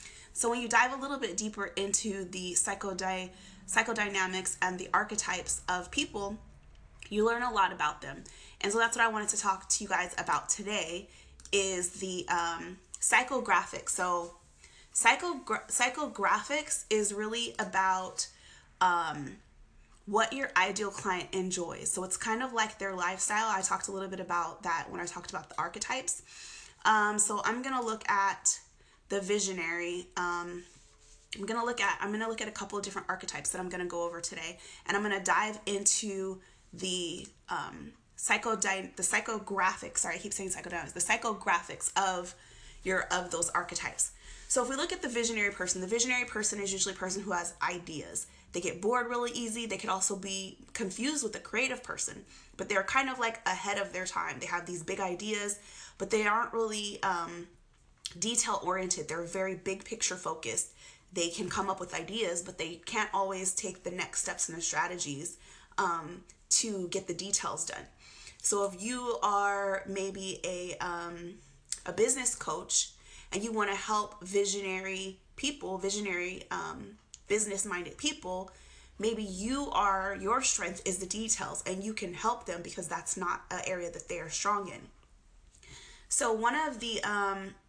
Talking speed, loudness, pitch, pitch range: 175 wpm, -32 LUFS, 195 Hz, 185-220 Hz